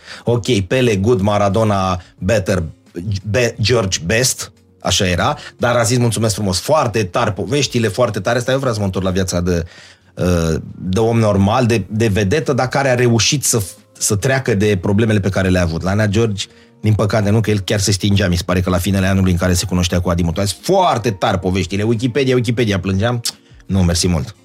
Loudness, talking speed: -16 LUFS, 200 wpm